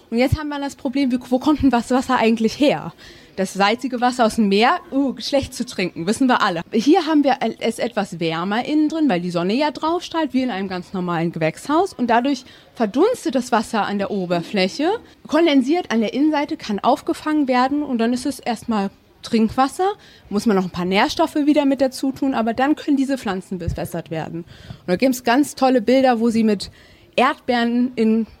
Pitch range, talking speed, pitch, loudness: 205-280 Hz, 205 wpm, 245 Hz, -19 LUFS